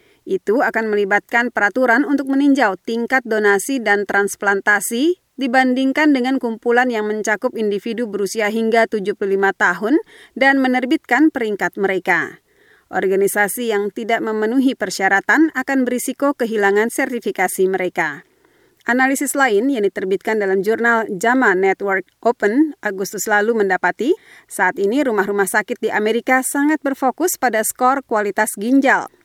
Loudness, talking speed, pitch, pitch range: -17 LUFS, 120 wpm, 230 Hz, 205-265 Hz